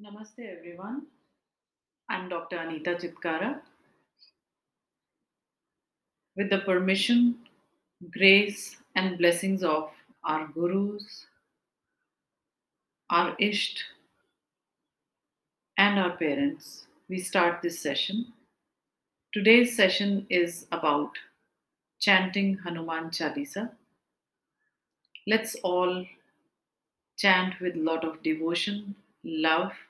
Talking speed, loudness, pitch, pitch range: 80 wpm, -27 LUFS, 185 Hz, 170-205 Hz